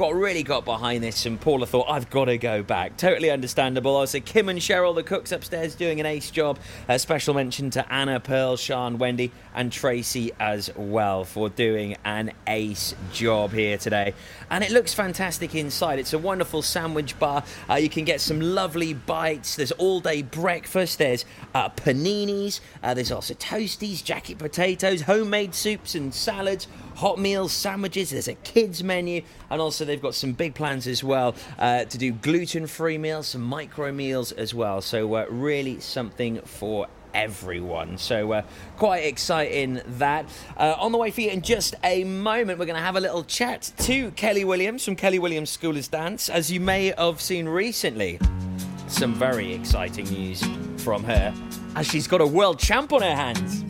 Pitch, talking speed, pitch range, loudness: 150 Hz, 185 wpm, 120-180 Hz, -25 LUFS